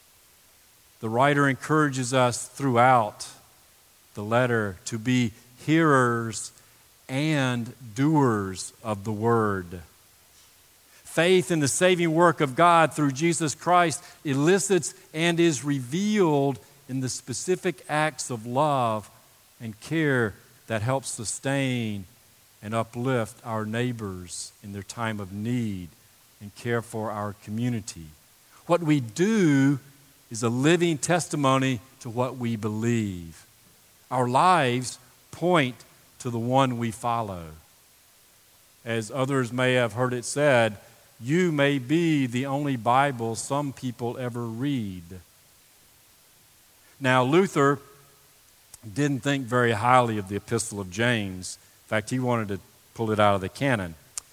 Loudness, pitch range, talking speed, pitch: -25 LUFS, 110-140 Hz, 125 wpm, 125 Hz